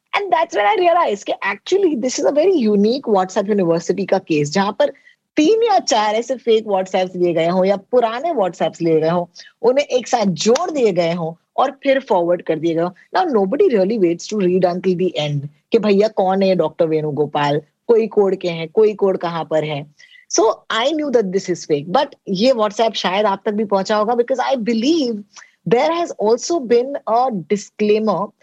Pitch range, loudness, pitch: 175-250 Hz, -17 LUFS, 210 Hz